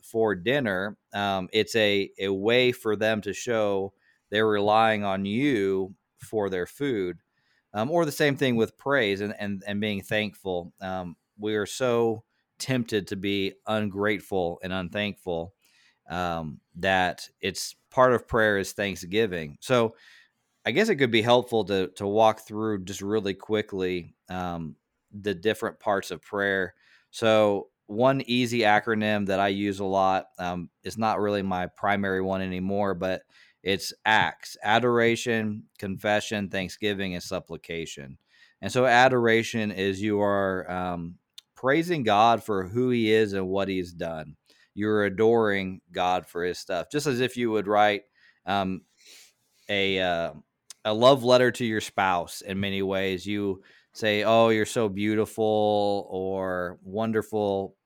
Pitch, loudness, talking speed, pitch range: 100 Hz, -26 LUFS, 145 wpm, 95-110 Hz